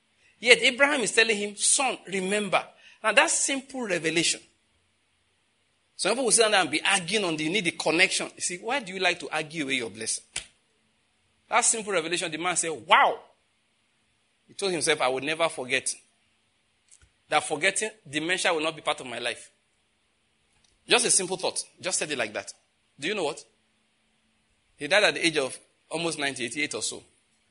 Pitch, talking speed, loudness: 160 Hz, 180 wpm, -25 LUFS